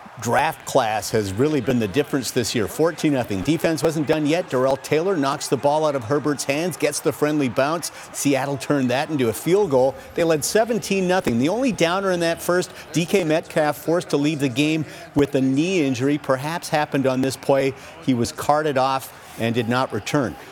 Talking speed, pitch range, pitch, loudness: 200 wpm, 135-160 Hz, 150 Hz, -21 LUFS